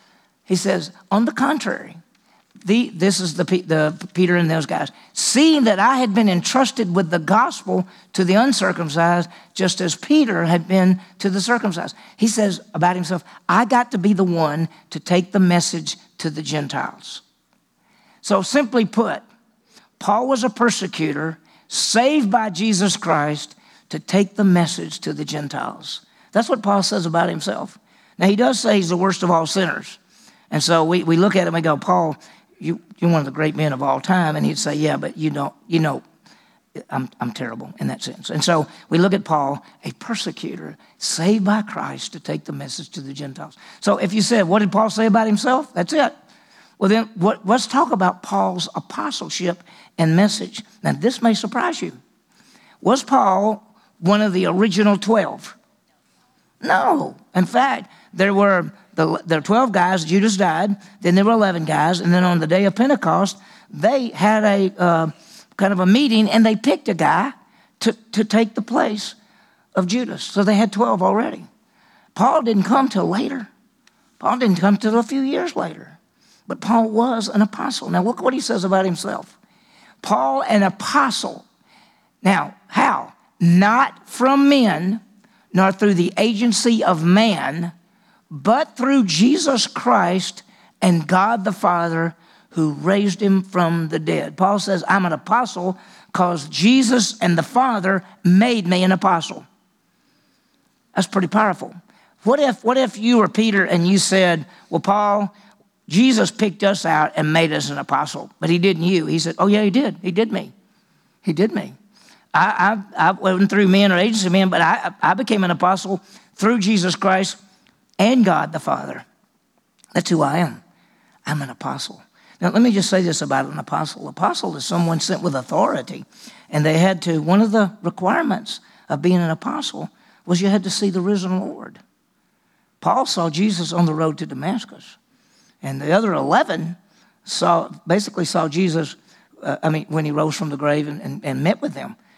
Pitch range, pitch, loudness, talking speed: 175-220 Hz, 195 Hz, -19 LUFS, 180 wpm